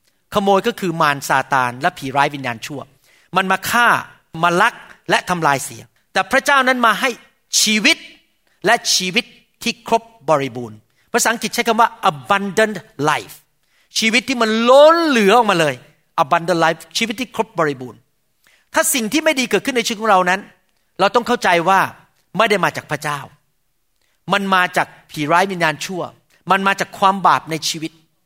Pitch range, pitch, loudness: 160-230 Hz, 190 Hz, -16 LUFS